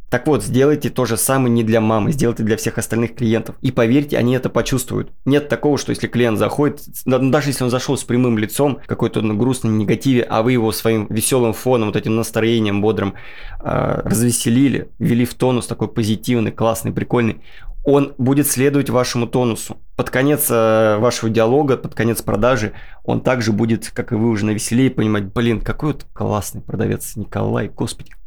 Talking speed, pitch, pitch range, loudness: 175 wpm, 115 Hz, 110-130 Hz, -18 LUFS